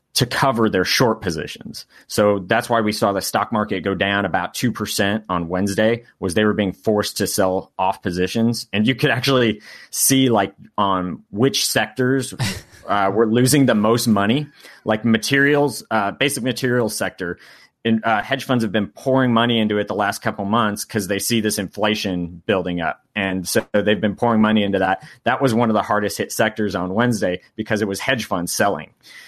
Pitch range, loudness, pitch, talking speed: 100-120 Hz, -19 LUFS, 110 Hz, 195 wpm